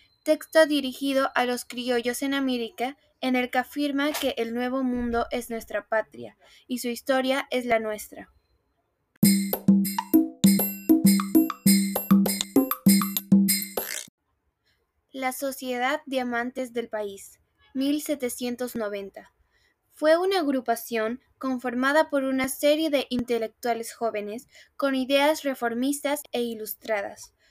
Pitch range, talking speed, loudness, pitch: 220-275 Hz, 100 wpm, -25 LUFS, 250 Hz